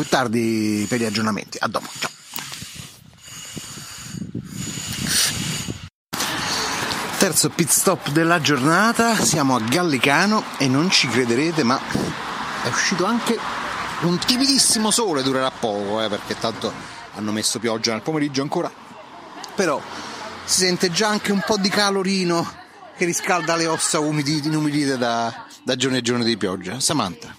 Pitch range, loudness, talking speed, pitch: 120-185 Hz, -20 LUFS, 135 wpm, 150 Hz